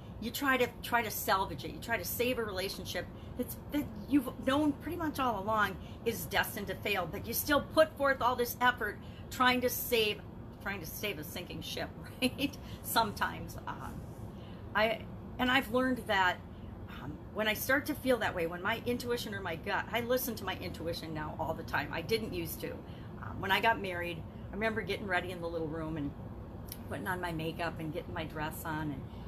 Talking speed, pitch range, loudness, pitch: 205 wpm, 170-255 Hz, -34 LUFS, 225 Hz